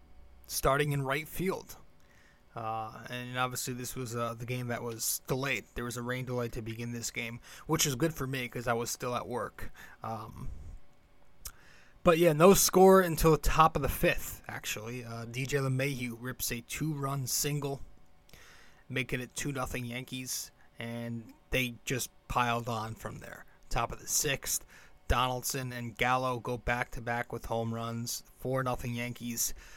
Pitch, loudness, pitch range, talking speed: 125 Hz, -32 LUFS, 115-135 Hz, 165 wpm